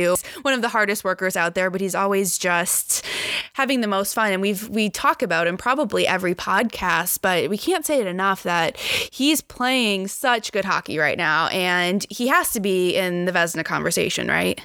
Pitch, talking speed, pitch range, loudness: 200 Hz, 195 wpm, 180-250 Hz, -21 LUFS